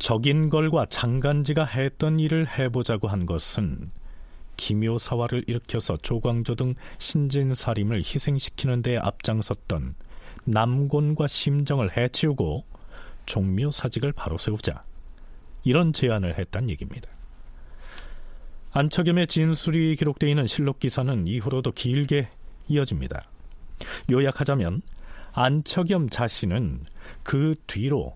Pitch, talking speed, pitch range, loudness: 125 Hz, 260 characters per minute, 100-145 Hz, -25 LUFS